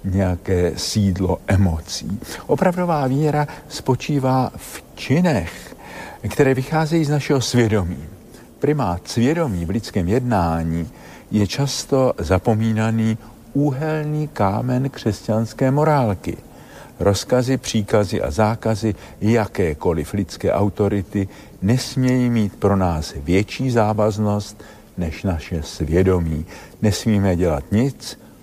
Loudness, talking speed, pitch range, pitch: -20 LUFS, 95 wpm, 95-130 Hz, 105 Hz